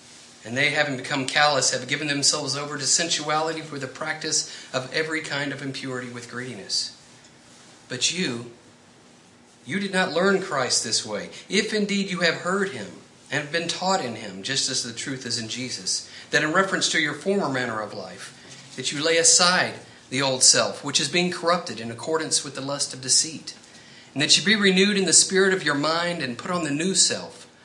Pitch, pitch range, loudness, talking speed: 145 Hz, 125-170 Hz, -22 LUFS, 200 wpm